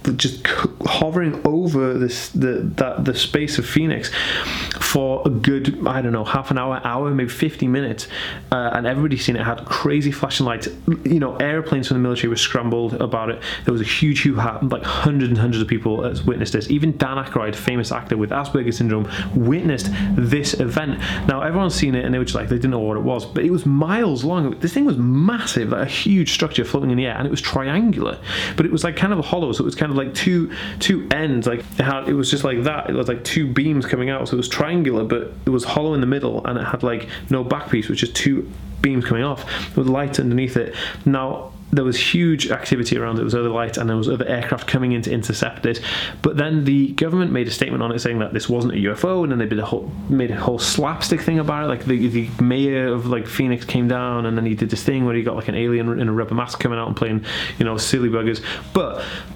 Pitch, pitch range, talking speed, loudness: 130 Hz, 115-145 Hz, 245 wpm, -20 LUFS